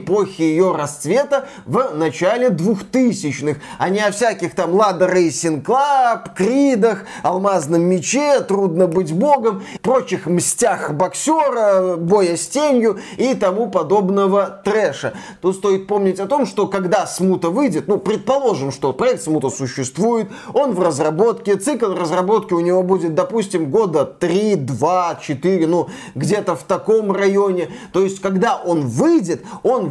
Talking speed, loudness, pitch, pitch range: 140 wpm, -17 LUFS, 190 Hz, 175-220 Hz